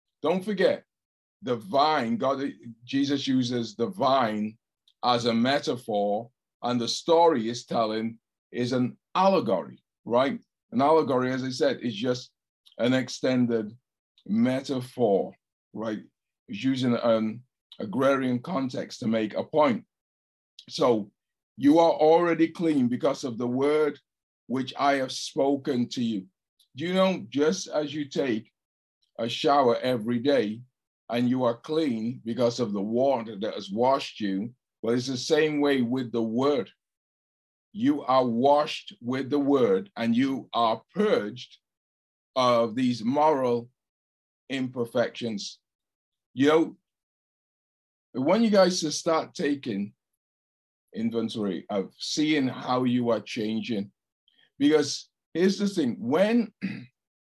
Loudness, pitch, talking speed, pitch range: -26 LUFS, 125 Hz, 125 wpm, 115-150 Hz